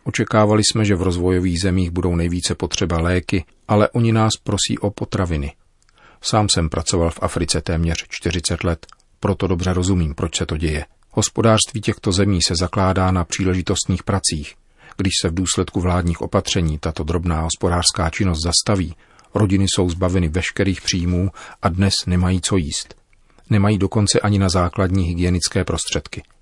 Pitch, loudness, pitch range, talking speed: 90 Hz, -19 LUFS, 85-100 Hz, 150 wpm